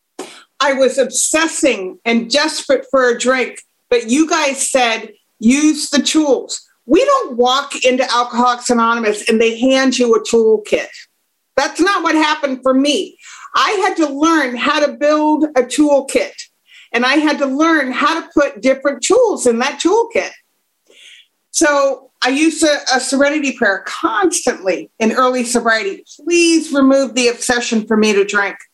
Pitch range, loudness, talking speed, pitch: 245-305 Hz, -14 LUFS, 155 wpm, 270 Hz